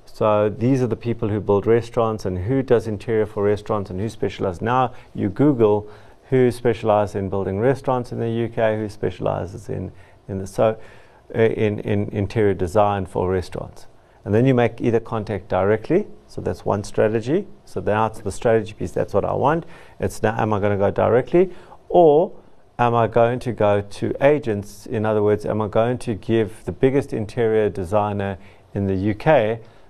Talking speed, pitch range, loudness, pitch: 180 wpm, 100-115 Hz, -21 LUFS, 110 Hz